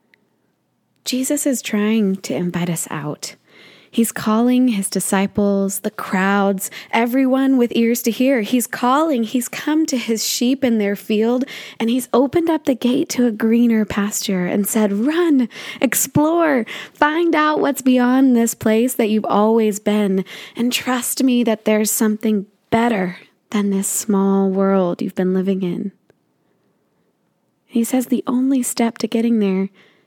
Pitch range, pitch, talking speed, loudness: 200-255 Hz, 230 Hz, 150 wpm, -18 LUFS